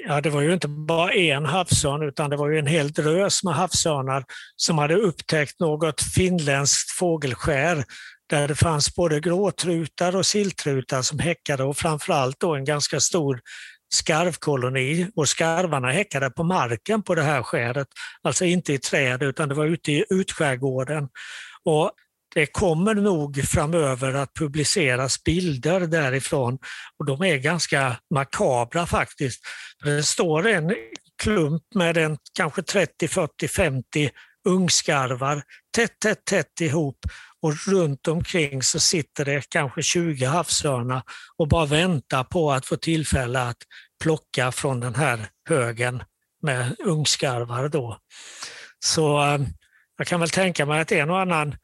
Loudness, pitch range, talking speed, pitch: -23 LUFS, 135-170 Hz, 145 wpm, 155 Hz